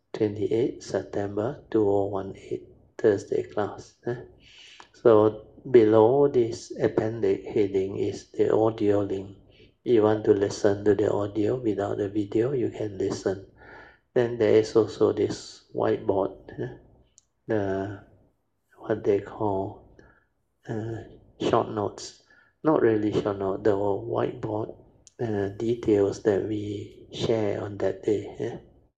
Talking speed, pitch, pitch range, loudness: 120 wpm, 105 Hz, 100-115 Hz, -26 LUFS